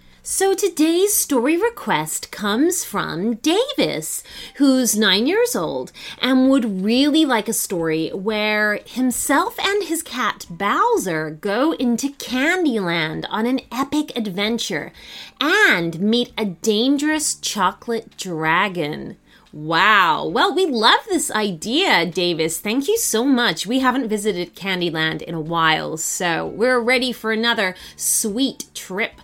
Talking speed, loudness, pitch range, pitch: 125 wpm, -19 LUFS, 205-290 Hz, 235 Hz